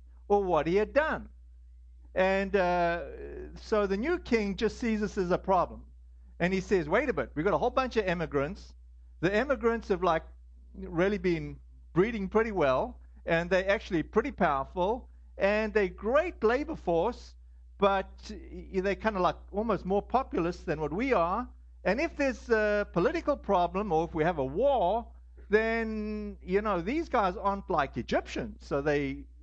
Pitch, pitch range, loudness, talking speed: 190 Hz, 145-220 Hz, -29 LUFS, 170 wpm